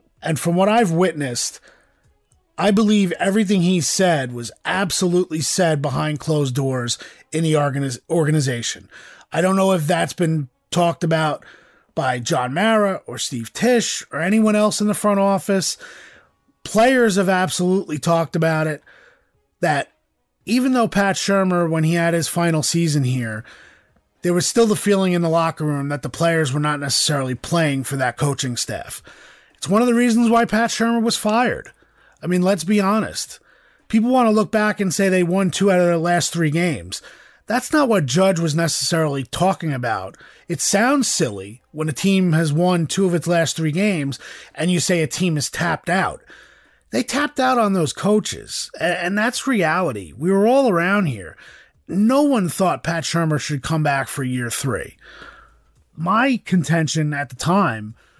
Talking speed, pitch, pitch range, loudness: 175 wpm, 170 Hz, 150-200 Hz, -19 LUFS